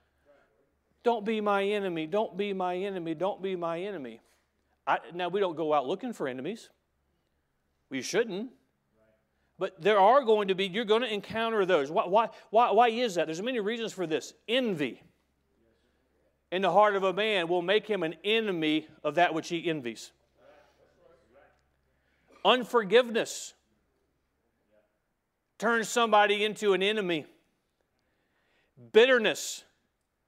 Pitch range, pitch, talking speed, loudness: 160-220 Hz, 195 Hz, 135 wpm, -28 LUFS